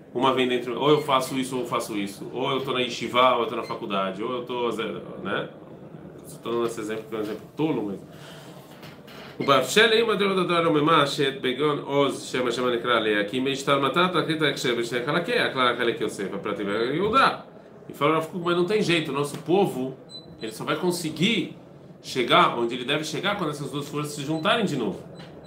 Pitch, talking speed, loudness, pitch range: 145 Hz, 230 wpm, -24 LUFS, 125-165 Hz